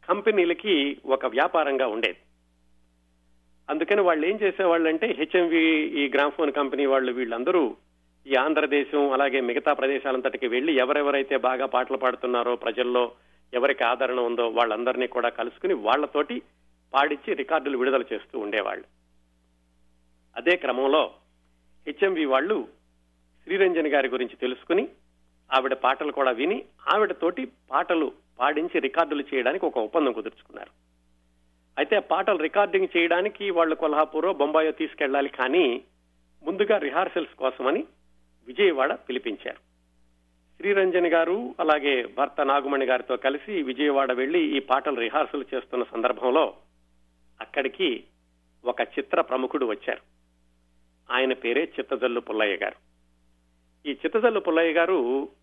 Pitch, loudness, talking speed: 130 Hz, -25 LUFS, 110 wpm